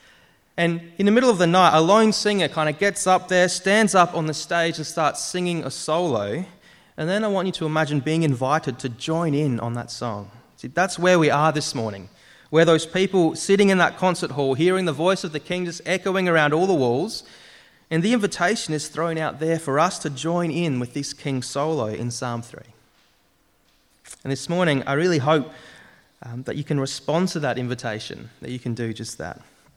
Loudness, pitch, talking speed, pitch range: -22 LUFS, 160 Hz, 215 wpm, 135-180 Hz